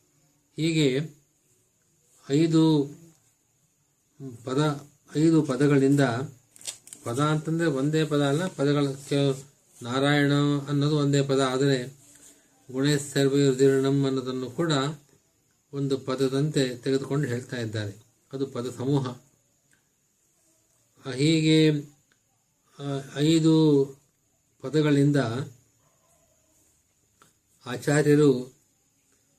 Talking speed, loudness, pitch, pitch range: 65 wpm, -25 LUFS, 140 Hz, 135-145 Hz